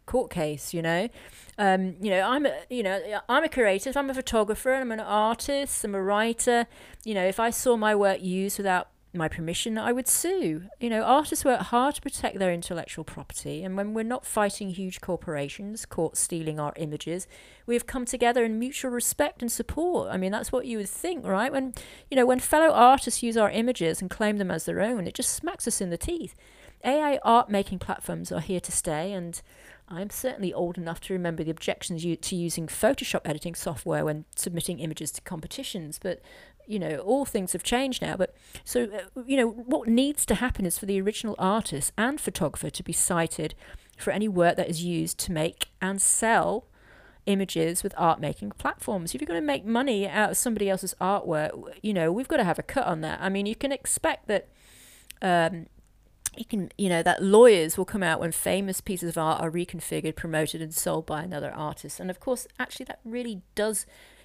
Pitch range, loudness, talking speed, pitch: 170-240 Hz, -27 LUFS, 205 wpm, 195 Hz